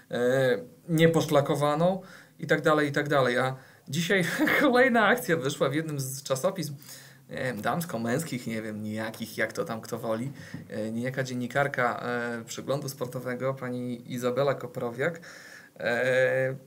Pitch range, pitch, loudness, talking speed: 120-155 Hz, 135 Hz, -28 LUFS, 135 wpm